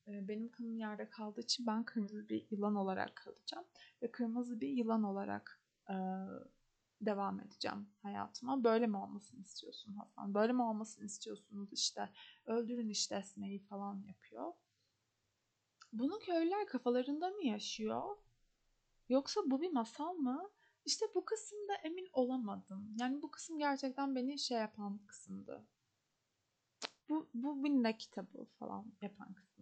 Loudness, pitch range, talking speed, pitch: -41 LUFS, 205-275 Hz, 130 wpm, 230 Hz